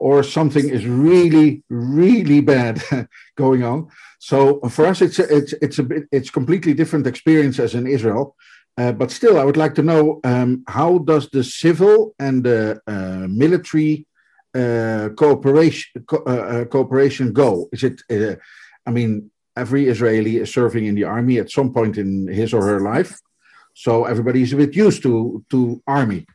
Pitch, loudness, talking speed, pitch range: 135 Hz, -17 LUFS, 170 wpm, 120-150 Hz